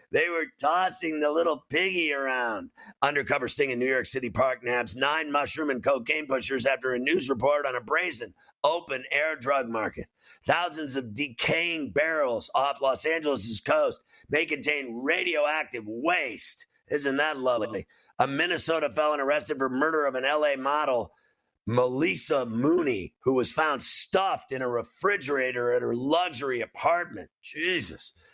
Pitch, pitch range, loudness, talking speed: 145 Hz, 130-155 Hz, -27 LUFS, 150 wpm